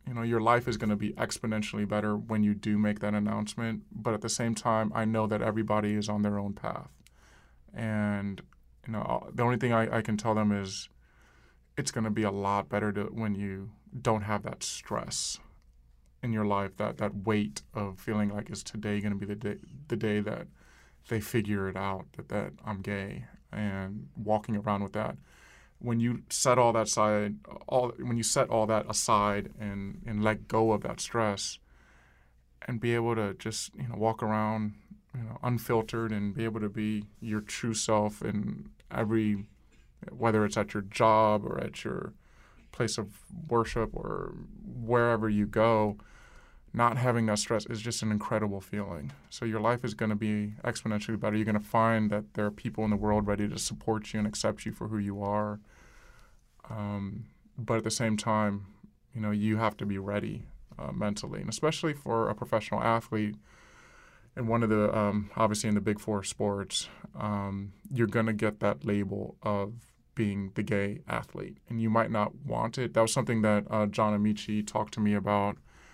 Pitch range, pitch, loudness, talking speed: 105-115 Hz, 105 Hz, -31 LUFS, 195 wpm